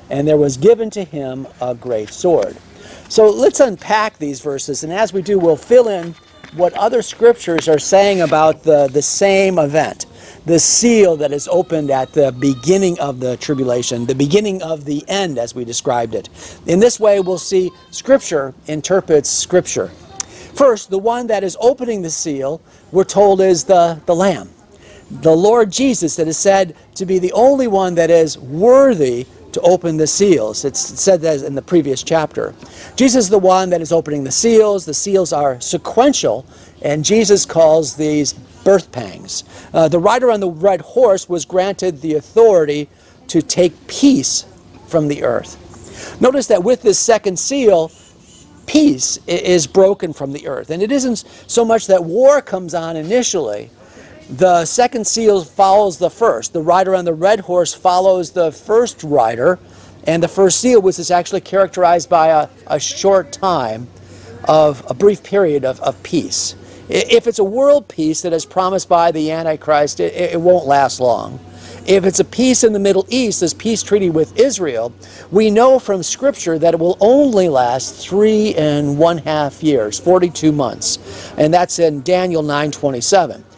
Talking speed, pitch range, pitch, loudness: 175 wpm, 150-200 Hz, 175 Hz, -14 LUFS